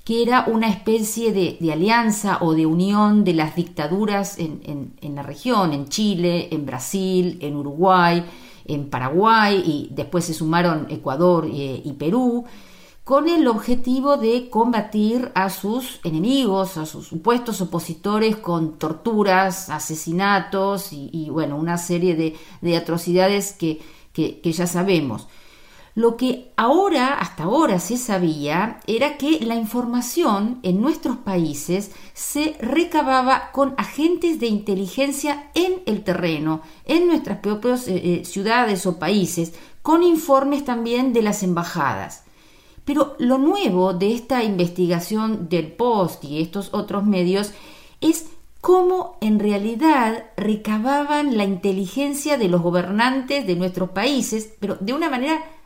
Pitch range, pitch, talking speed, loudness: 170-245 Hz, 200 Hz, 135 wpm, -20 LUFS